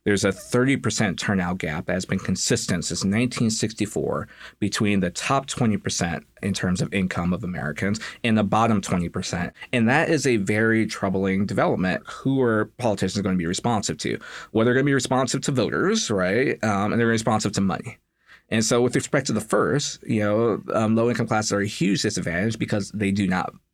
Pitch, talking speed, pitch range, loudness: 110 Hz, 195 wpm, 100-120 Hz, -23 LUFS